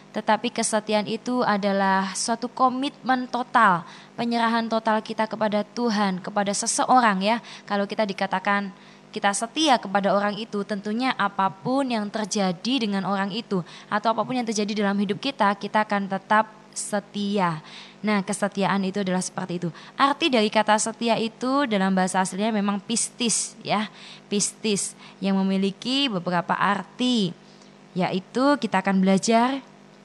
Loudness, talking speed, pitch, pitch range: -24 LUFS, 135 wpm, 210 Hz, 195-230 Hz